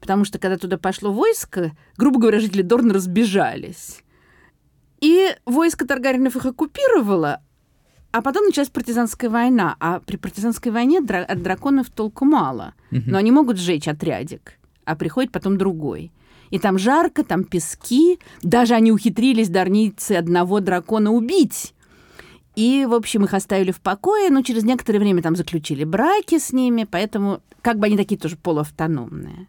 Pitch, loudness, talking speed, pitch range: 215 Hz, -19 LUFS, 150 wpm, 185-260 Hz